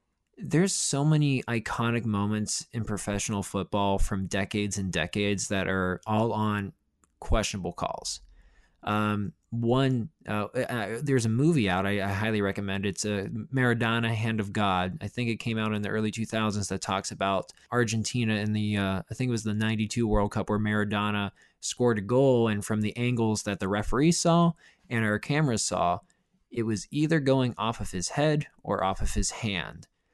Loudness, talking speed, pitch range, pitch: -28 LUFS, 180 wpm, 100-120 Hz, 110 Hz